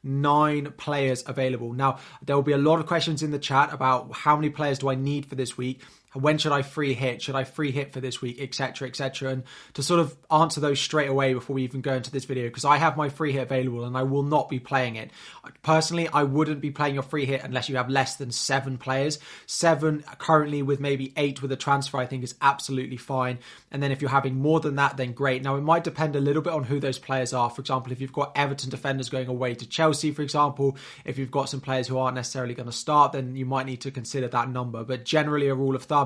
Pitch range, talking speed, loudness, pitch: 130-145 Hz, 260 wpm, -26 LUFS, 135 Hz